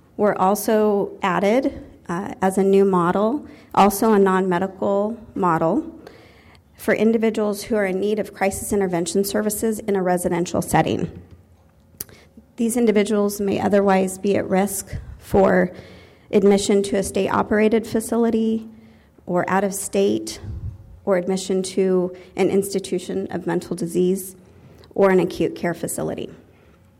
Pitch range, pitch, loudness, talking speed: 180-210 Hz, 195 Hz, -20 LUFS, 125 wpm